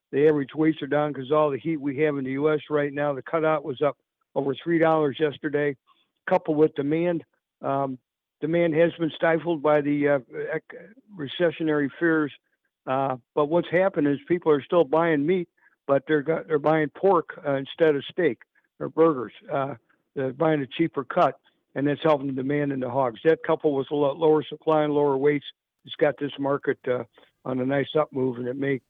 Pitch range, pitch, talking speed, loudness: 140-160 Hz, 150 Hz, 200 wpm, -25 LUFS